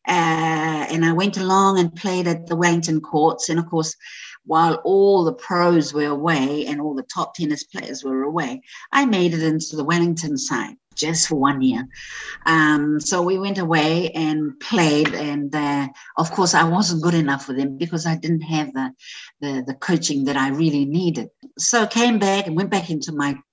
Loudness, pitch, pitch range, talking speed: -20 LUFS, 160 Hz, 150-180 Hz, 195 wpm